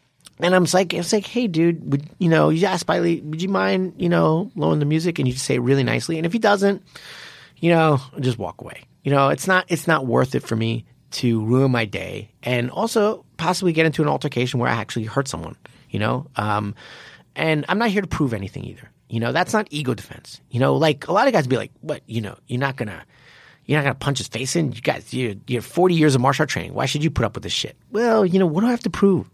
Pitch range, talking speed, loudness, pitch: 125-175 Hz, 265 wpm, -21 LUFS, 145 Hz